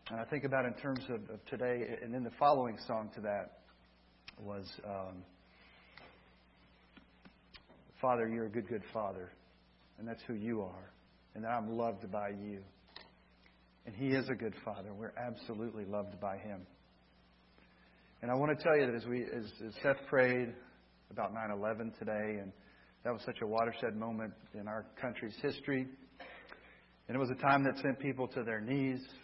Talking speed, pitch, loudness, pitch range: 170 wpm, 110 Hz, -38 LUFS, 100-125 Hz